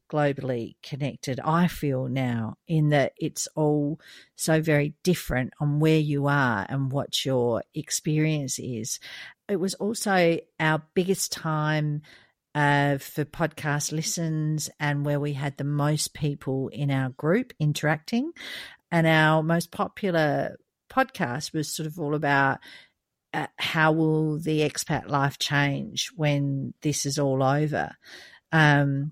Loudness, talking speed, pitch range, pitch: -26 LUFS, 135 wpm, 140-160 Hz, 150 Hz